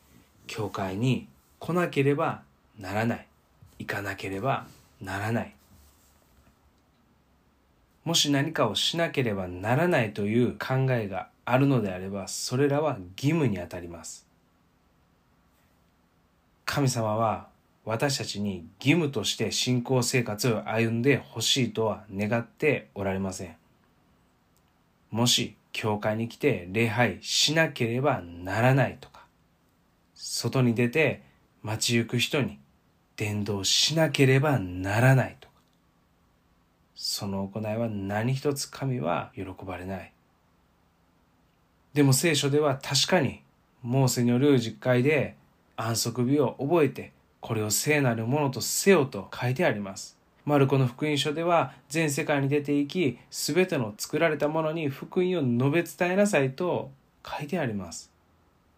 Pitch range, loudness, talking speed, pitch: 90-140 Hz, -26 LUFS, 245 characters per minute, 115 Hz